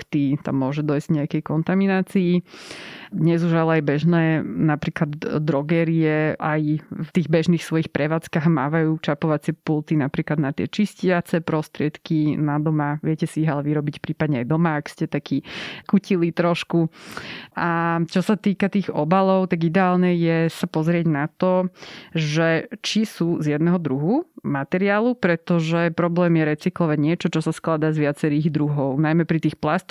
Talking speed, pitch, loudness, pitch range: 155 wpm, 165 Hz, -21 LUFS, 150-175 Hz